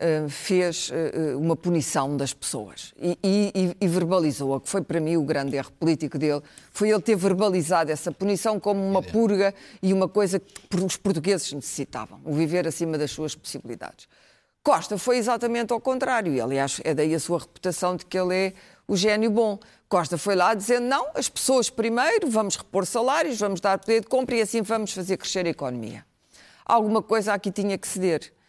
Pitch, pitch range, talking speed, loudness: 190 Hz, 160-215 Hz, 185 wpm, -24 LUFS